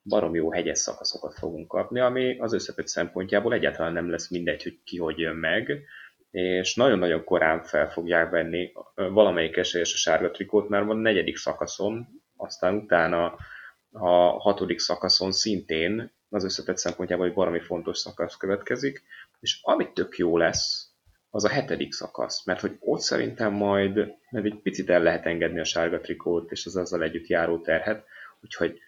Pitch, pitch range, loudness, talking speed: 90 Hz, 85-105 Hz, -26 LUFS, 165 wpm